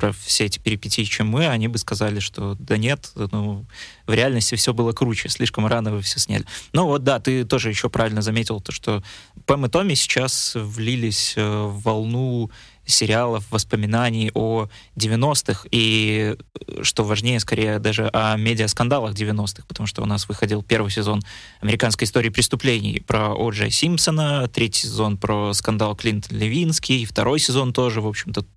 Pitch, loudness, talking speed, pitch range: 110 Hz, -21 LUFS, 160 wpm, 105-125 Hz